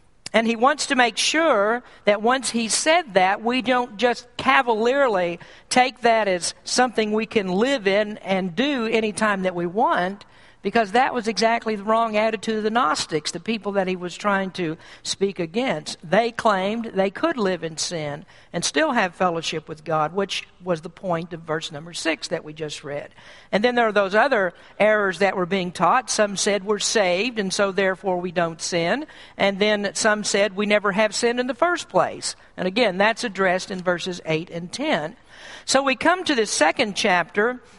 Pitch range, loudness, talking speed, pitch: 180-235 Hz, -22 LUFS, 195 wpm, 205 Hz